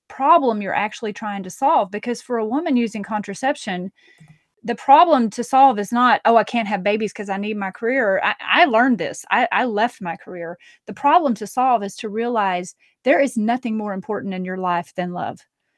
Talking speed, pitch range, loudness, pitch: 205 wpm, 195-240 Hz, -19 LUFS, 215 Hz